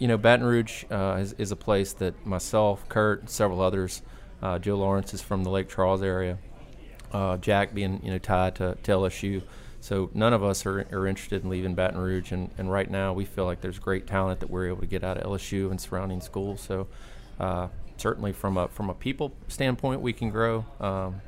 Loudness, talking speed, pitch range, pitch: -28 LUFS, 220 wpm, 95-105 Hz, 95 Hz